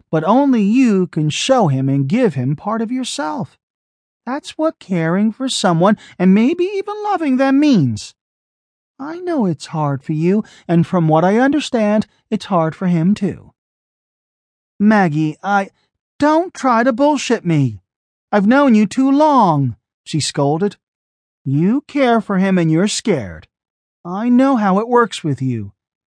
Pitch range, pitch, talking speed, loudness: 160-260 Hz, 205 Hz, 155 wpm, -16 LUFS